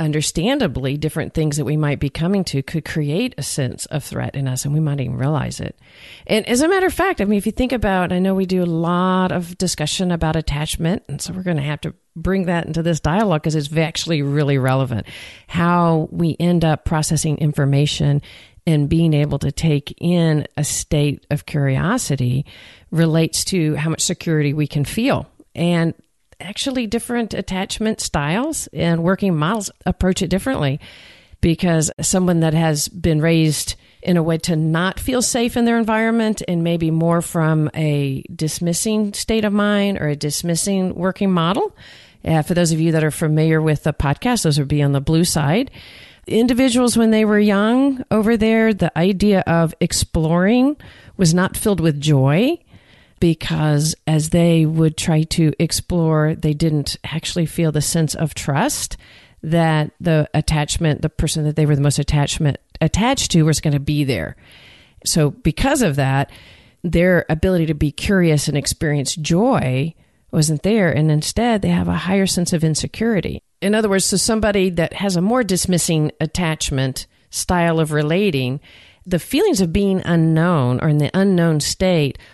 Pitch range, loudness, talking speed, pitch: 150-185 Hz, -18 LUFS, 175 wpm, 165 Hz